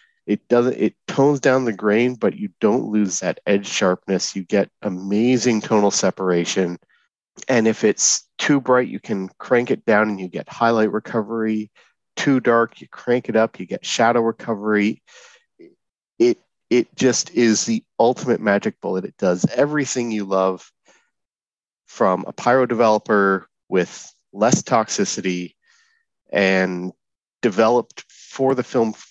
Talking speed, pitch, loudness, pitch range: 140 wpm, 115 Hz, -19 LUFS, 100-130 Hz